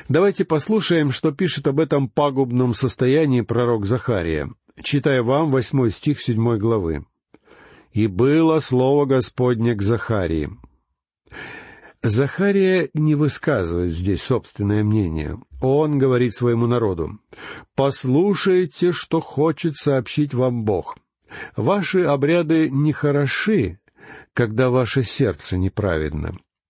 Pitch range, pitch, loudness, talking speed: 115-150 Hz, 130 Hz, -20 LUFS, 100 wpm